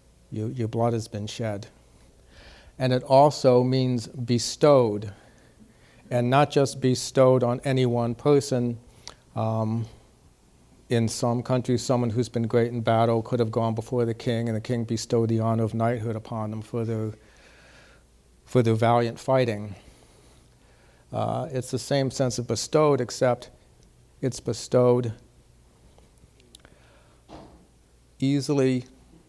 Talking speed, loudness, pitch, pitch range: 125 wpm, -24 LUFS, 120 Hz, 110-125 Hz